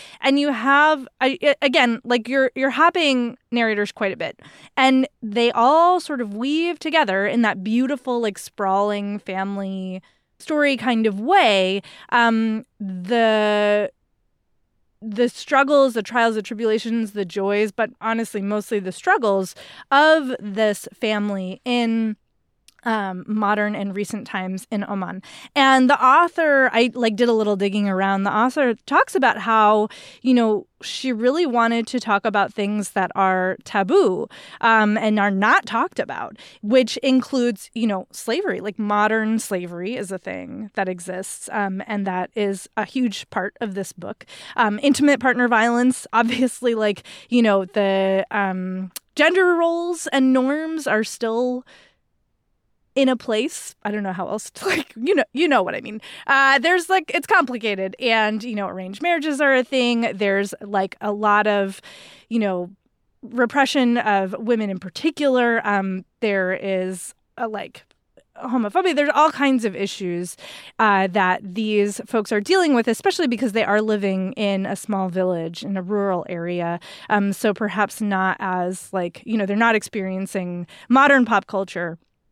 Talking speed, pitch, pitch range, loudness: 155 wpm, 220 Hz, 200-255 Hz, -20 LUFS